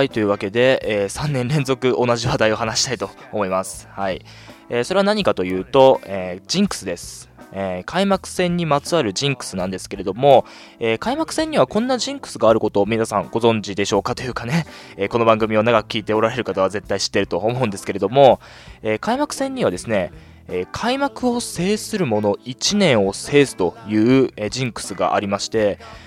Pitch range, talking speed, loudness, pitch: 105-155 Hz, 375 characters per minute, -19 LUFS, 120 Hz